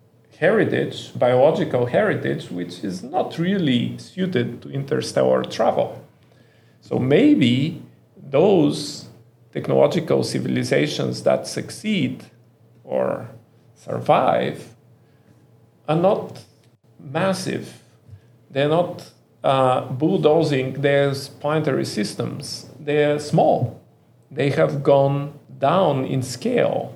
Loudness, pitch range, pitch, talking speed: -21 LUFS, 120-150 Hz, 140 Hz, 85 wpm